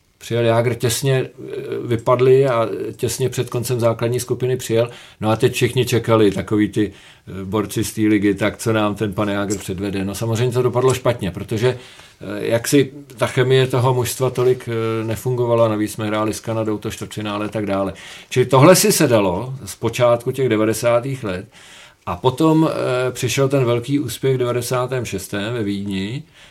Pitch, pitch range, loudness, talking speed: 120 Hz, 105-125 Hz, -19 LUFS, 165 wpm